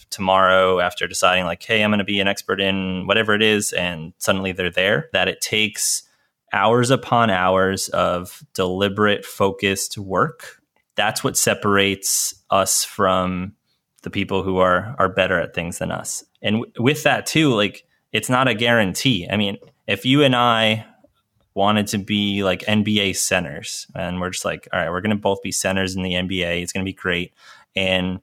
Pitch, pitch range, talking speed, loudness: 100 Hz, 95-105 Hz, 185 wpm, -19 LUFS